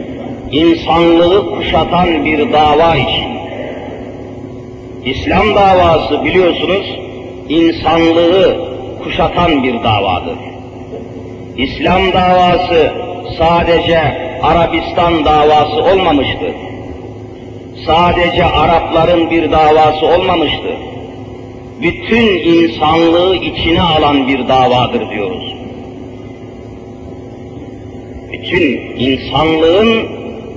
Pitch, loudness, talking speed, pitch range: 140 Hz, -11 LUFS, 65 wpm, 125-165 Hz